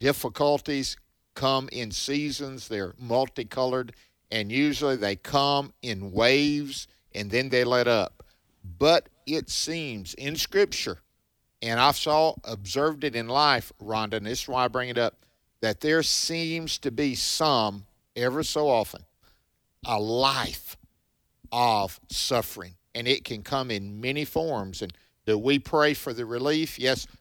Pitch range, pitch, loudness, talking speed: 110-145 Hz, 125 Hz, -26 LUFS, 145 wpm